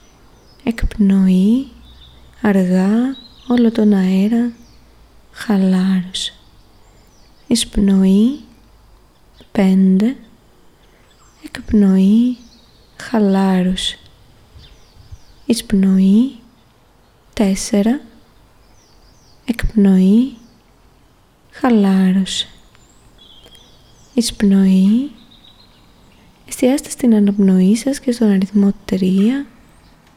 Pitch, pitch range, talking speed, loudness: 205 Hz, 190-235 Hz, 45 wpm, -15 LUFS